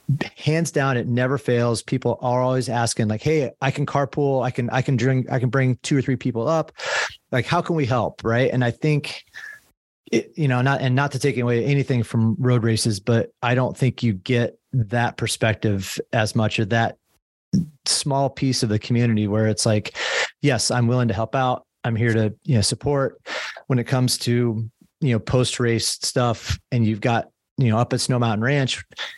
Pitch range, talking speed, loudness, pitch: 115-135 Hz, 205 wpm, -22 LUFS, 125 Hz